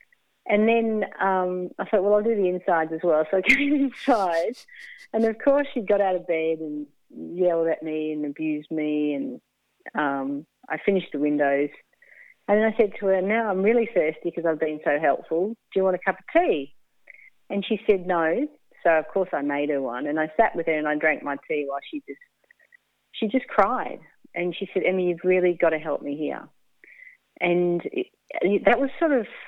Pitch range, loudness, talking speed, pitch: 155-230 Hz, -24 LUFS, 210 wpm, 185 Hz